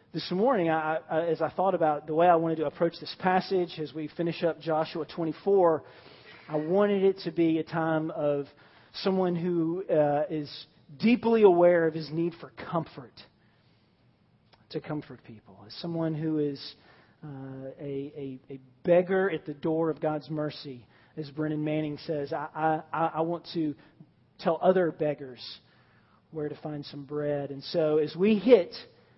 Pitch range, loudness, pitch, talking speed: 145-170 Hz, -28 LUFS, 155 Hz, 165 wpm